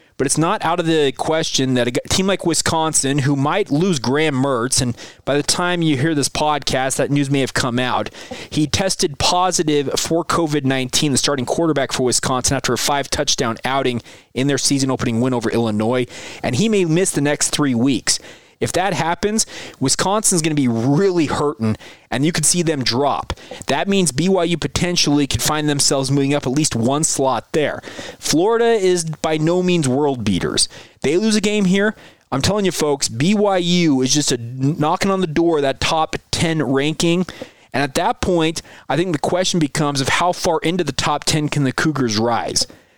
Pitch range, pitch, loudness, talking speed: 135-170 Hz, 150 Hz, -18 LUFS, 195 wpm